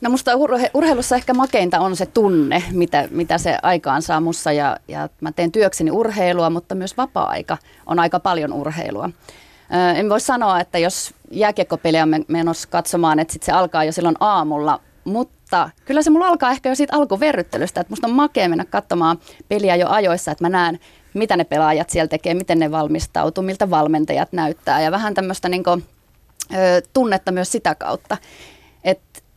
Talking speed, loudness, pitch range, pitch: 175 wpm, -18 LUFS, 165-210 Hz, 175 Hz